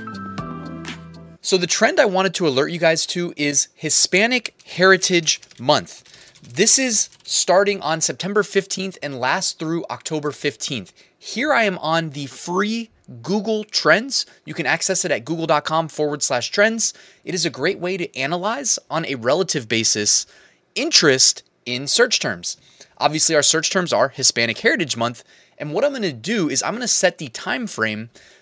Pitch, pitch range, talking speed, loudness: 165 Hz, 140-190 Hz, 160 wpm, -19 LUFS